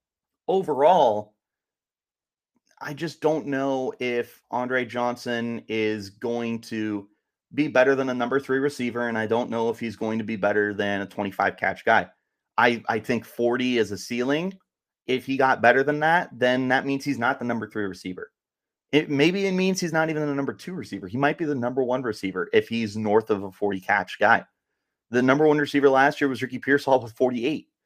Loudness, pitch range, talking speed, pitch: -24 LUFS, 110-140 Hz, 200 wpm, 125 Hz